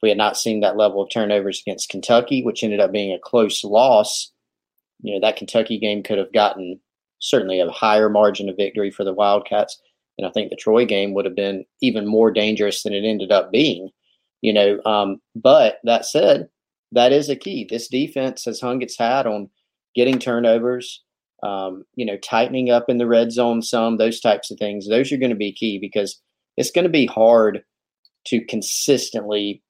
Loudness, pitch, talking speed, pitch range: -19 LUFS, 110 Hz, 200 wpm, 100-115 Hz